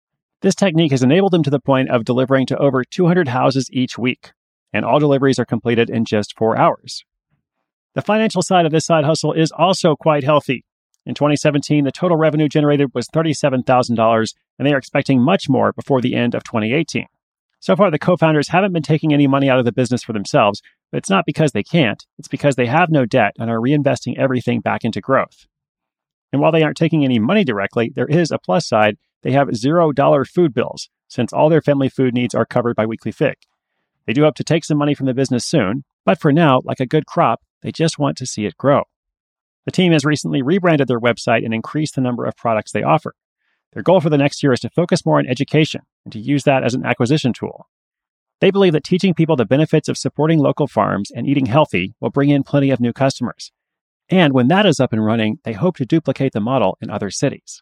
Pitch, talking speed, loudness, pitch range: 140 Hz, 225 wpm, -17 LUFS, 125-155 Hz